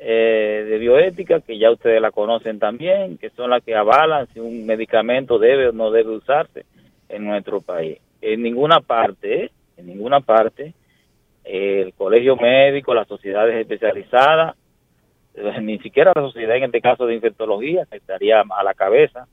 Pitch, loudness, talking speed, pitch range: 115 Hz, -17 LUFS, 160 wpm, 110-140 Hz